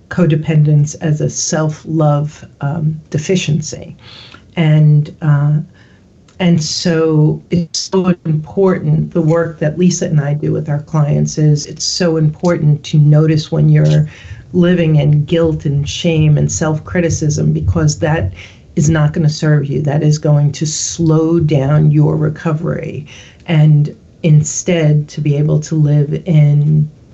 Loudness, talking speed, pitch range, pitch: -13 LUFS, 135 wpm, 150-165 Hz, 155 Hz